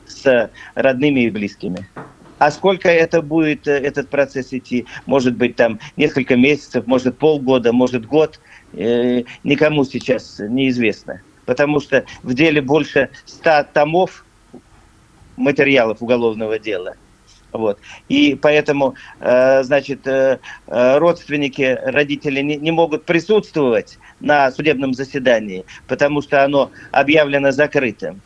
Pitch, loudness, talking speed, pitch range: 140 Hz, -16 LUFS, 110 wpm, 125-150 Hz